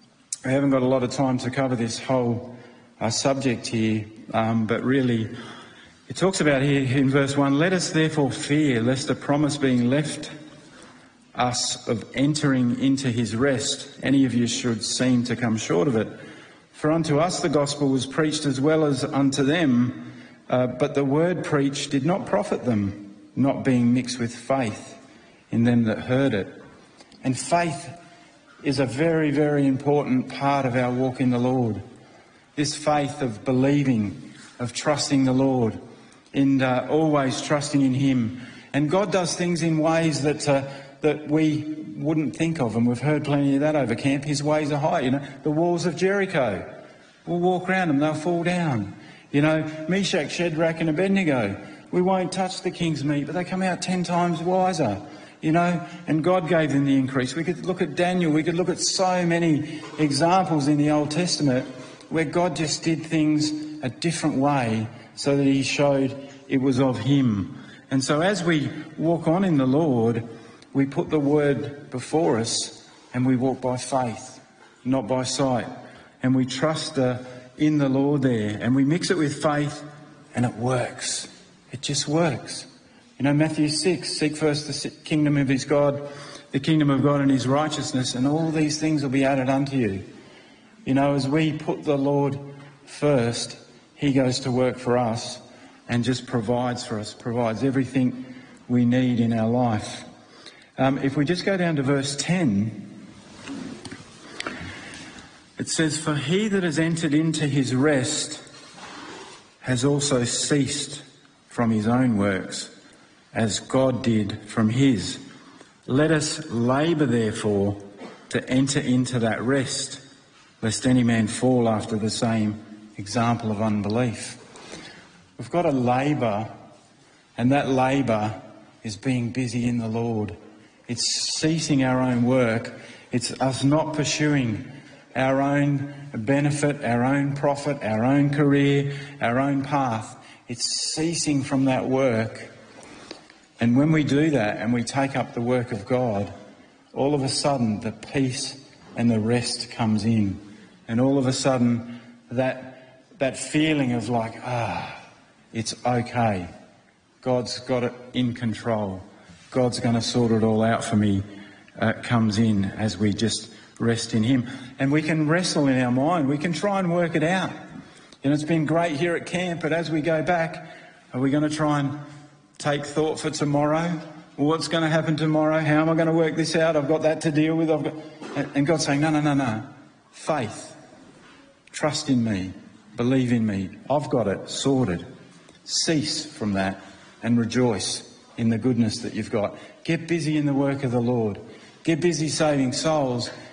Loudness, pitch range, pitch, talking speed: -23 LUFS, 120-150 Hz, 135 Hz, 170 wpm